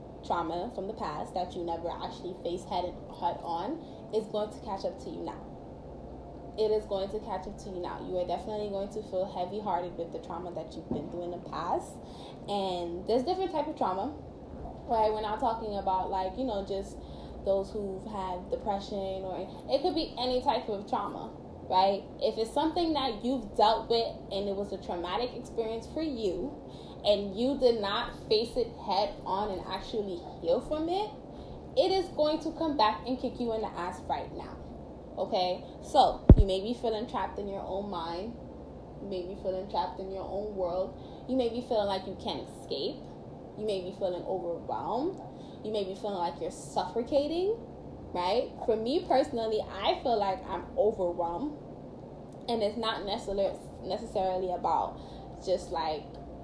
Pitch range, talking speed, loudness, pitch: 185-245 Hz, 185 wpm, -32 LUFS, 205 Hz